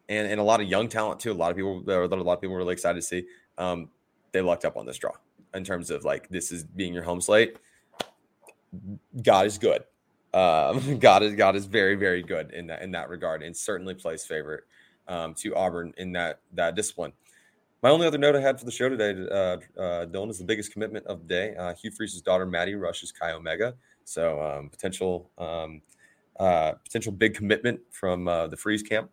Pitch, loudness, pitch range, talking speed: 95 Hz, -27 LUFS, 85-105 Hz, 220 wpm